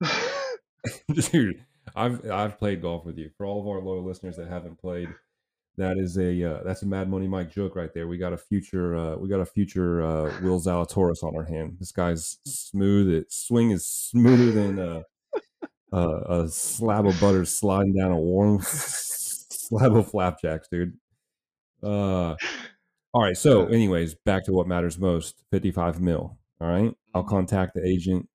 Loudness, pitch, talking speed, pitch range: -25 LUFS, 95 Hz, 180 wpm, 85-100 Hz